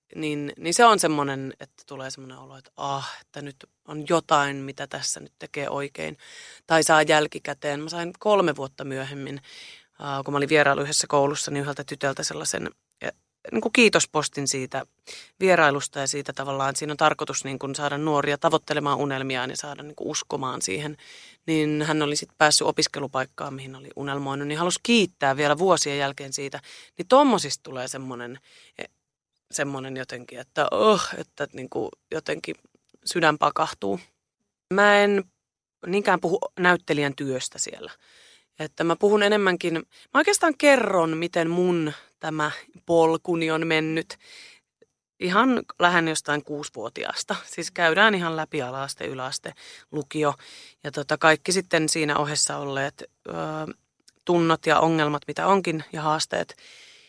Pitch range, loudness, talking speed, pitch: 140-170 Hz, -24 LUFS, 150 wpm, 150 Hz